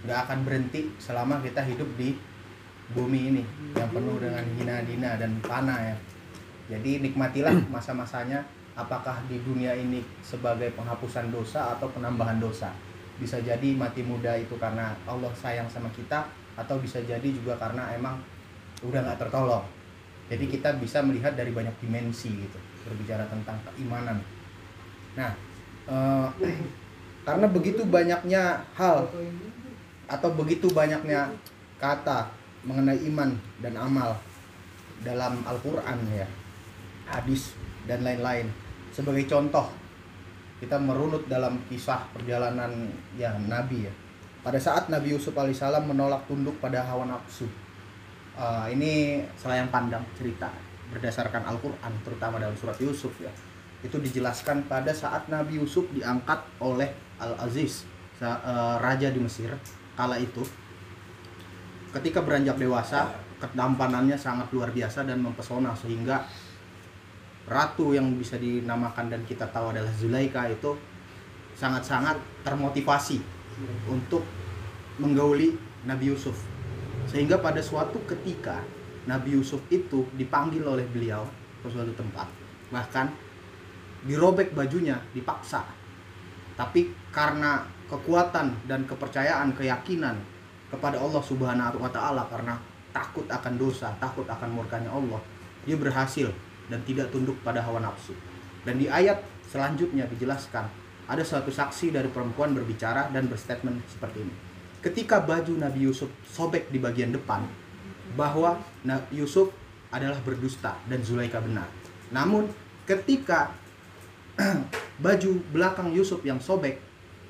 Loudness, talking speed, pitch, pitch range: -29 LUFS, 120 wpm, 125 Hz, 110-140 Hz